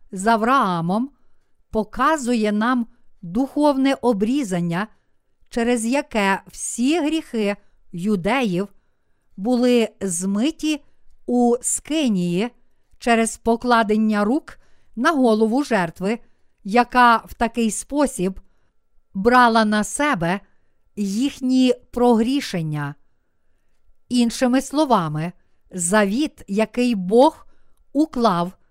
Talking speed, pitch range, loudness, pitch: 75 wpm, 200-255 Hz, -20 LUFS, 230 Hz